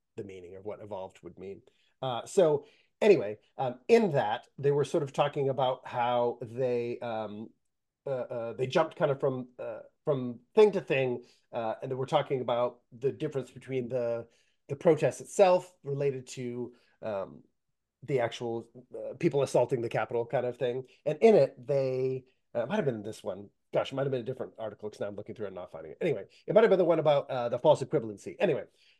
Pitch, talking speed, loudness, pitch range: 130 Hz, 205 wpm, -30 LUFS, 120-150 Hz